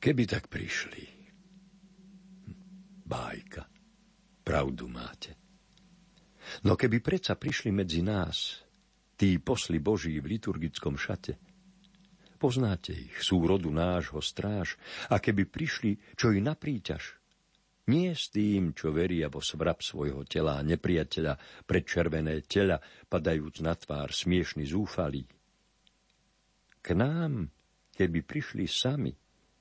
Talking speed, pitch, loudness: 110 wpm, 100 Hz, -31 LUFS